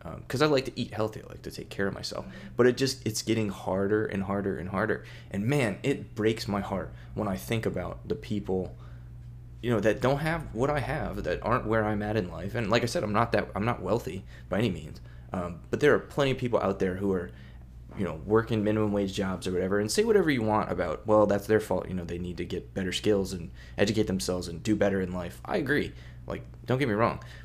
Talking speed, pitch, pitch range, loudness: 245 wpm, 105 Hz, 90-115 Hz, -29 LUFS